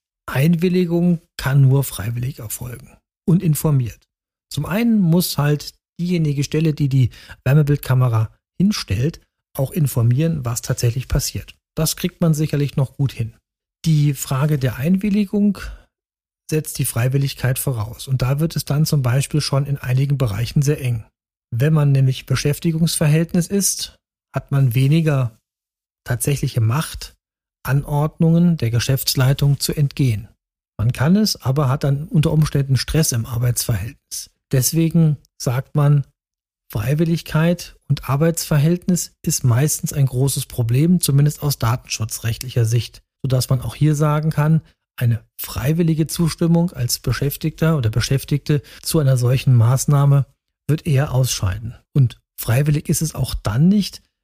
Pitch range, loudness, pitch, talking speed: 125-155 Hz, -19 LUFS, 140 Hz, 130 wpm